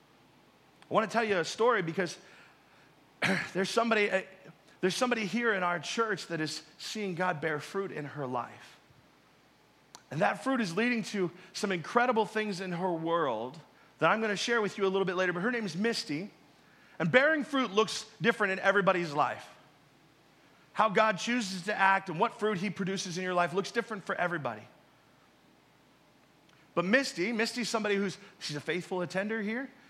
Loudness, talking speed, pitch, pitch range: -31 LUFS, 175 wpm, 195 Hz, 175-225 Hz